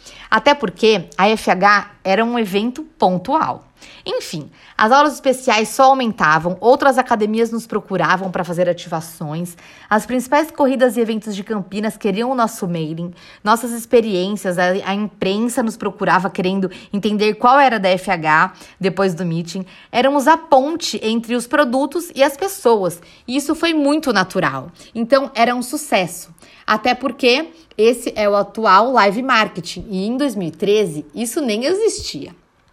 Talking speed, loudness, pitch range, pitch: 145 wpm, -17 LUFS, 190-260 Hz, 220 Hz